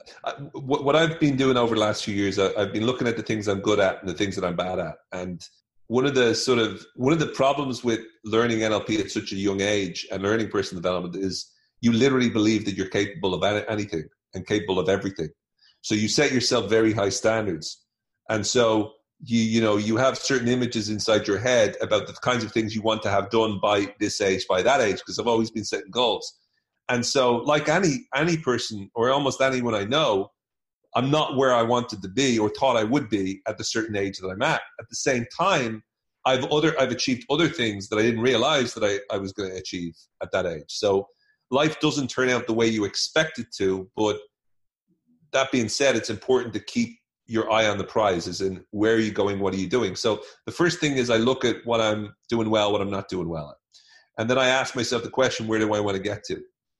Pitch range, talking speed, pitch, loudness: 100-125 Hz, 230 wpm, 110 Hz, -24 LUFS